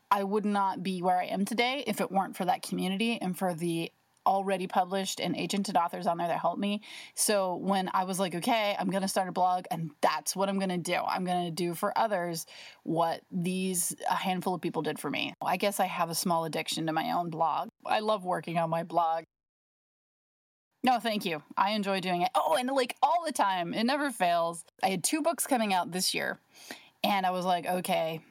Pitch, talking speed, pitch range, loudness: 185 Hz, 220 wpm, 170-205 Hz, -30 LUFS